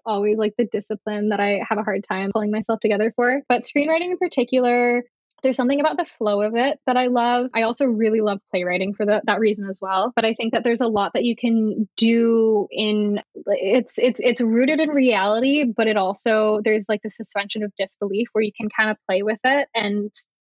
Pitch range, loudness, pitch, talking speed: 210-245 Hz, -20 LUFS, 220 Hz, 220 wpm